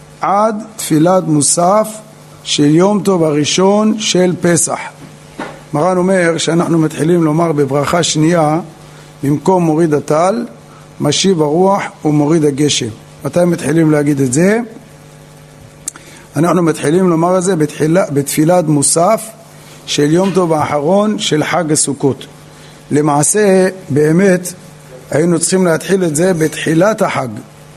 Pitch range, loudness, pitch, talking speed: 145-185 Hz, -12 LUFS, 160 Hz, 110 wpm